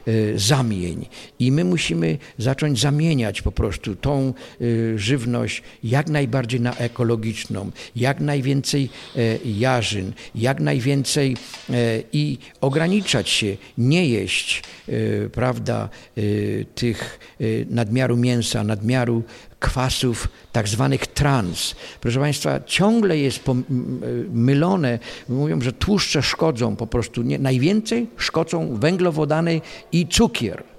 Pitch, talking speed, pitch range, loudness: 125 Hz, 95 wpm, 115-145 Hz, -21 LUFS